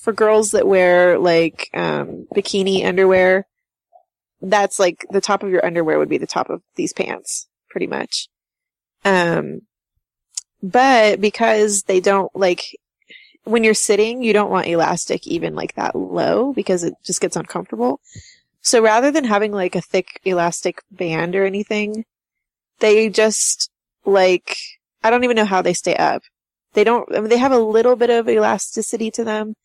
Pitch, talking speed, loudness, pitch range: 210 Hz, 165 wpm, -17 LUFS, 185-225 Hz